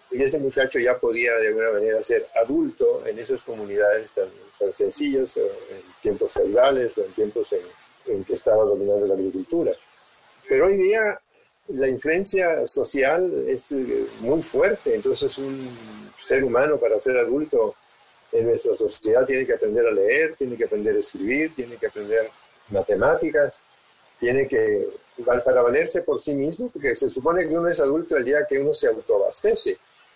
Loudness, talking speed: -21 LUFS, 170 wpm